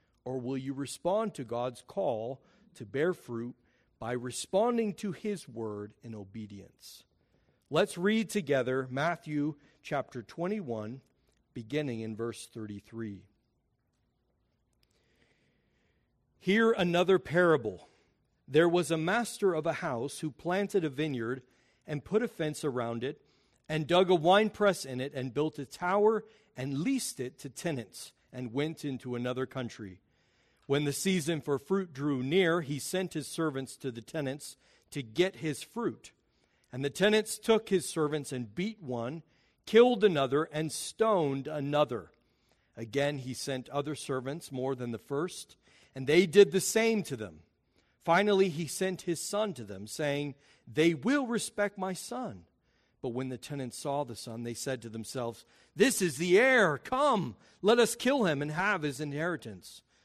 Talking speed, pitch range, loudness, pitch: 150 wpm, 125-185 Hz, -31 LUFS, 145 Hz